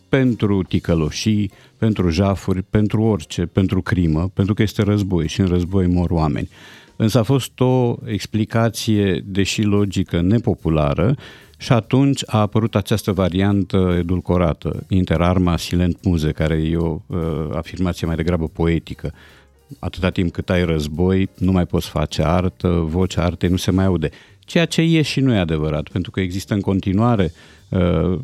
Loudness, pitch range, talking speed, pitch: -19 LUFS, 85-105 Hz, 155 wpm, 95 Hz